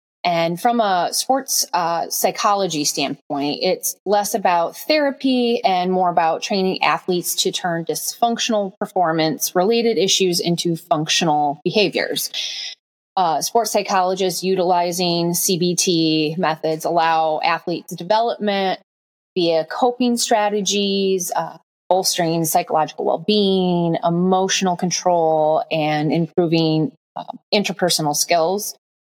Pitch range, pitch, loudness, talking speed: 165-200 Hz, 180 Hz, -19 LUFS, 100 wpm